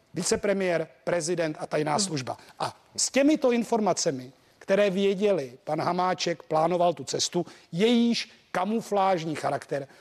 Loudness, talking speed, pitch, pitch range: -26 LUFS, 115 wpm, 175 Hz, 160-200 Hz